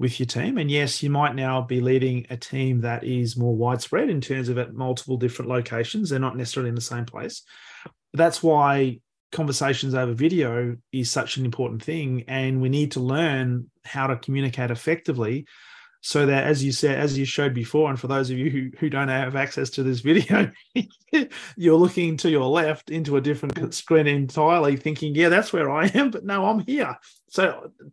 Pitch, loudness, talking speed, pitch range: 135 Hz, -23 LUFS, 200 wpm, 125-155 Hz